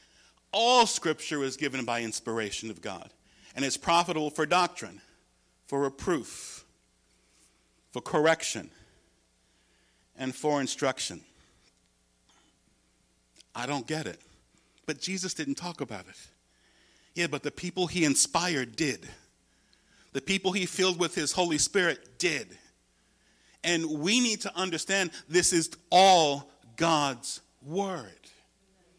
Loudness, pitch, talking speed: -28 LUFS, 145 Hz, 115 wpm